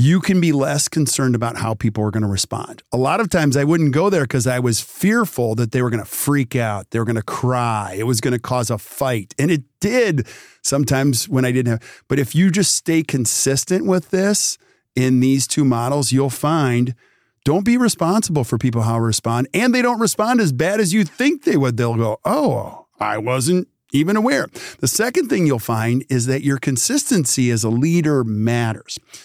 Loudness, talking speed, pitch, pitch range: -18 LUFS, 215 wpm, 135 Hz, 120-170 Hz